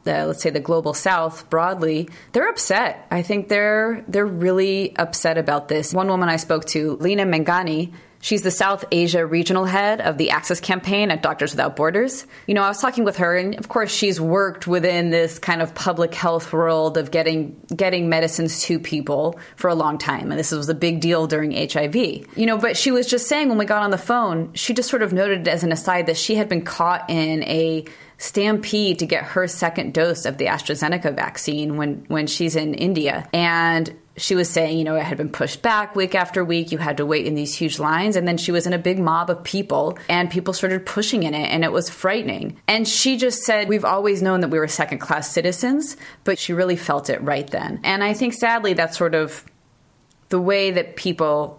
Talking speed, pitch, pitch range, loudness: 220 wpm, 175 Hz, 160-195 Hz, -20 LUFS